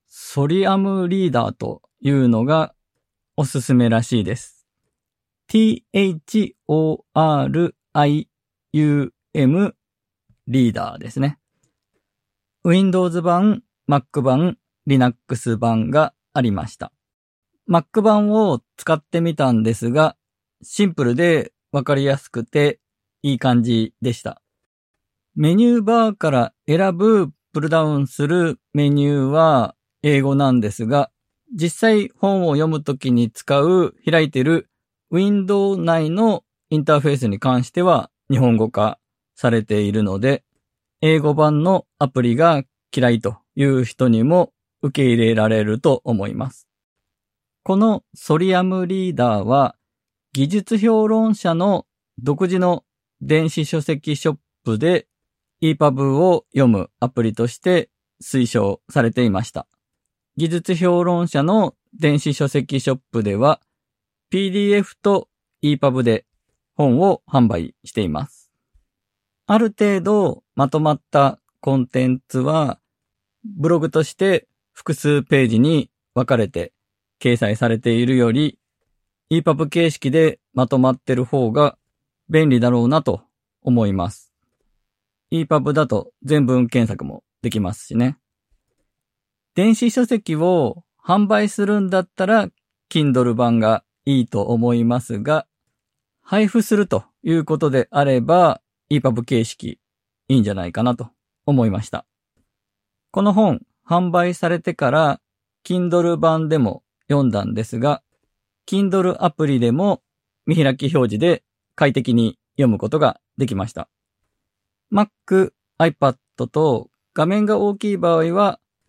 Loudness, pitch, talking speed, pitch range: -18 LUFS, 145 Hz, 255 characters per minute, 120-170 Hz